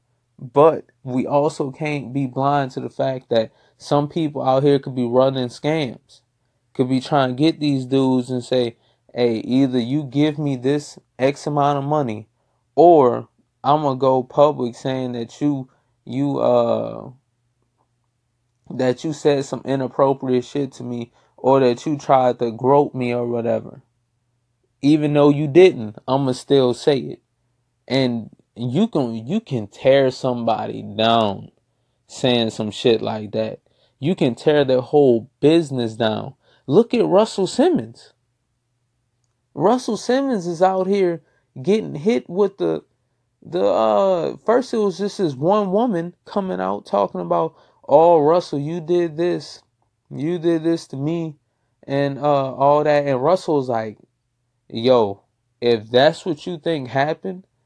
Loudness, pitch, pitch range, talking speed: -19 LUFS, 135 Hz, 120-155 Hz, 150 wpm